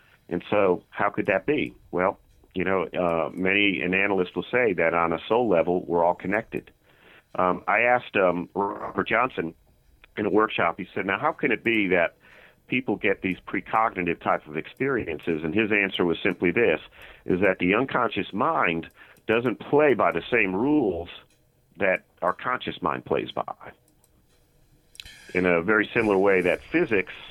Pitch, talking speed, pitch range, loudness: 90 Hz, 170 wpm, 85-105 Hz, -24 LUFS